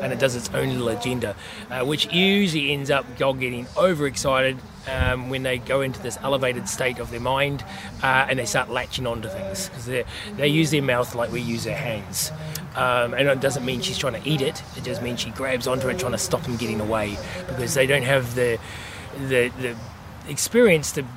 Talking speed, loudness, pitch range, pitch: 220 wpm, -23 LUFS, 120-140 Hz, 125 Hz